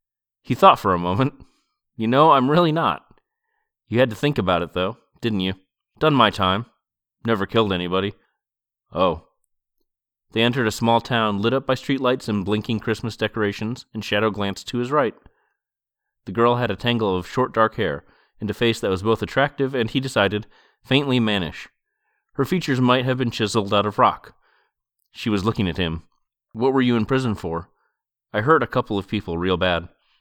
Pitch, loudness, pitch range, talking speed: 110 Hz, -21 LUFS, 100-125 Hz, 185 wpm